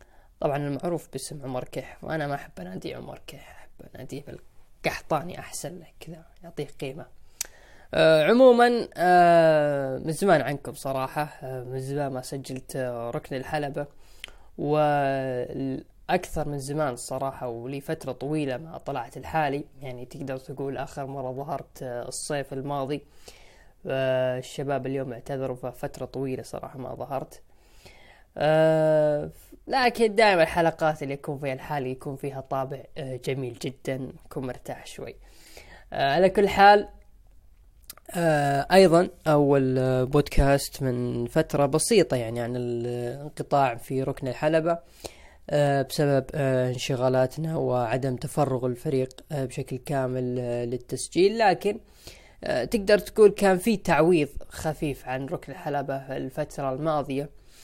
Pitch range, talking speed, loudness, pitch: 130-155 Hz, 110 wpm, -25 LUFS, 140 Hz